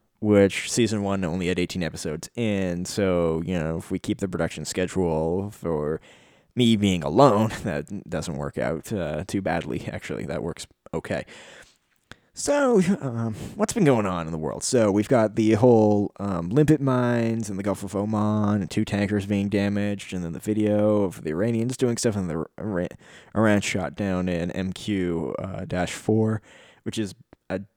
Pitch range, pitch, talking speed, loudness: 90-110 Hz, 100 Hz, 175 wpm, -24 LUFS